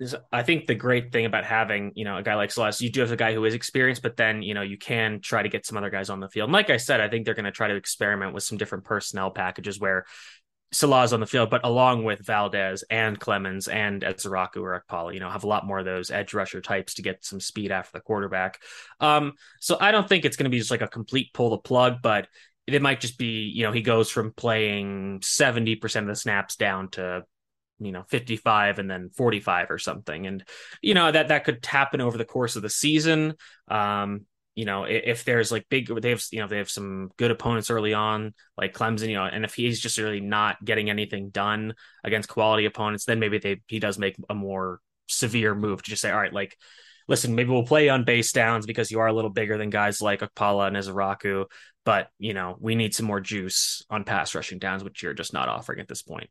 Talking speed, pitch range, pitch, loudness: 250 wpm, 100-120 Hz, 110 Hz, -25 LUFS